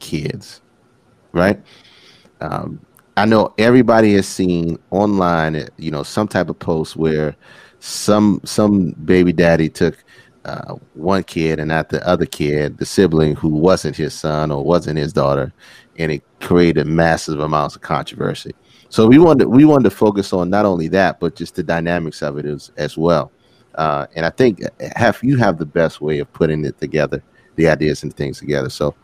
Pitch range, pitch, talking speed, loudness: 75-95 Hz, 85 Hz, 180 wpm, -16 LUFS